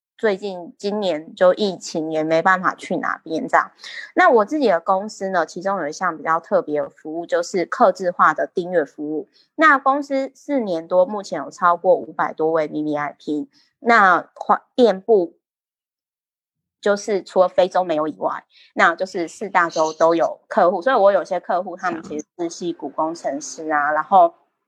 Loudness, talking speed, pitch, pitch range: -19 LUFS, 260 characters per minute, 180 Hz, 160-210 Hz